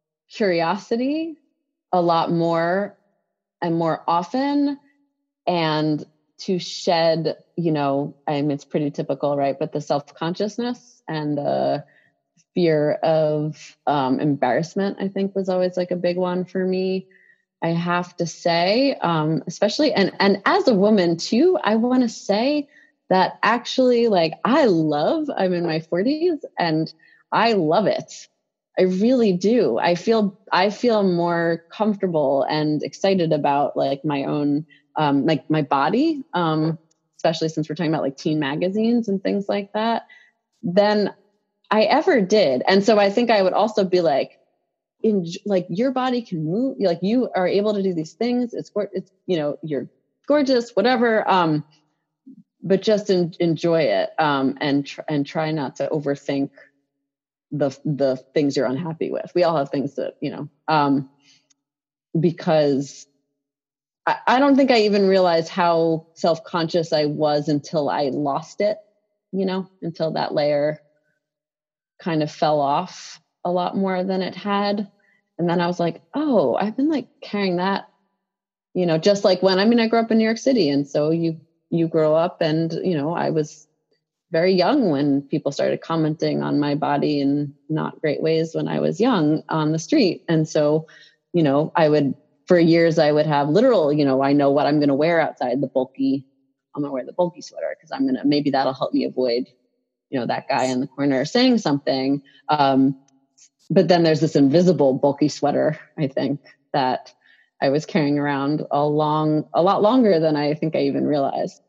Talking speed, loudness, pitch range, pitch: 175 wpm, -21 LUFS, 150-195 Hz, 165 Hz